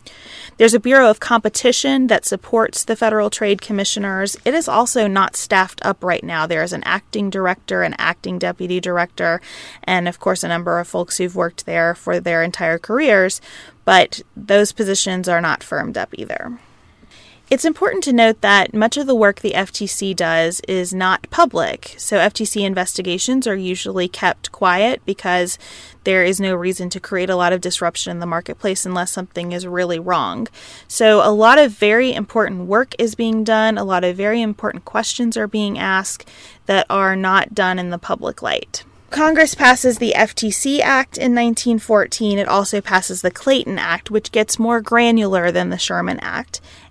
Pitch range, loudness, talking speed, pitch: 180-225 Hz, -17 LUFS, 180 wpm, 200 Hz